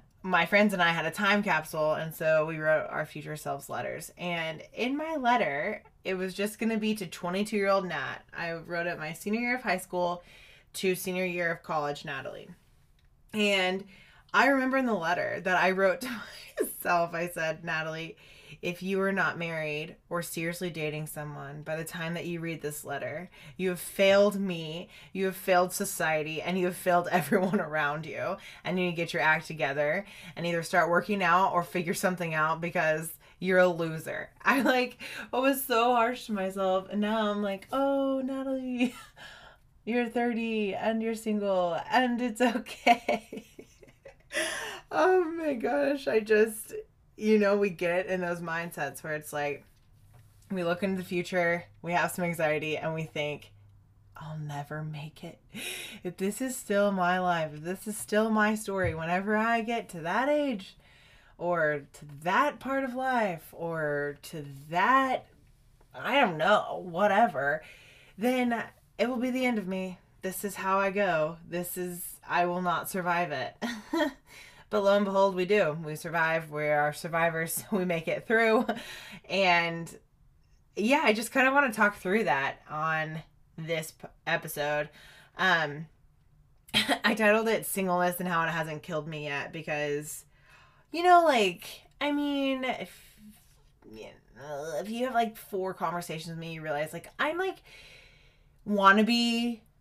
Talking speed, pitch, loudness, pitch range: 165 wpm, 180 Hz, -29 LUFS, 160-215 Hz